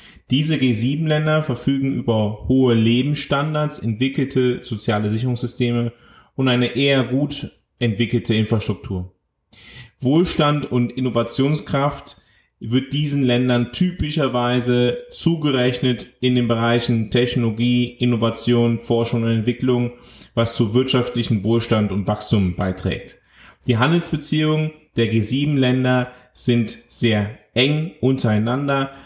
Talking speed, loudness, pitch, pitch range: 95 wpm, -20 LUFS, 125 Hz, 115-135 Hz